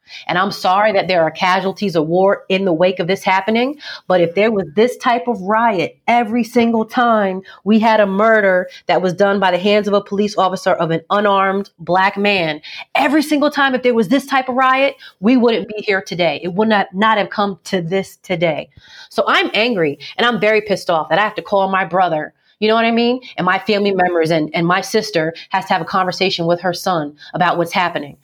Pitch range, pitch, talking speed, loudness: 180-220 Hz, 195 Hz, 230 wpm, -16 LUFS